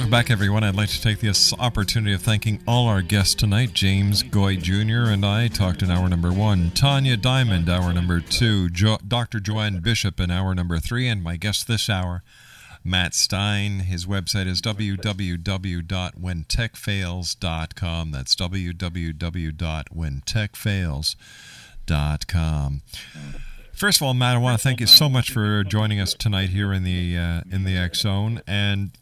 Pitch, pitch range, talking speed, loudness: 100 Hz, 90-110 Hz, 155 wpm, -21 LUFS